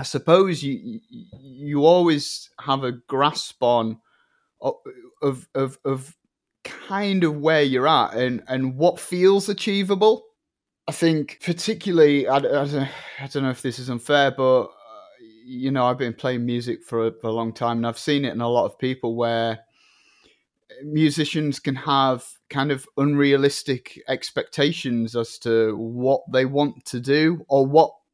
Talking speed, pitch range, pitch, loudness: 150 wpm, 125-165 Hz, 140 Hz, -22 LUFS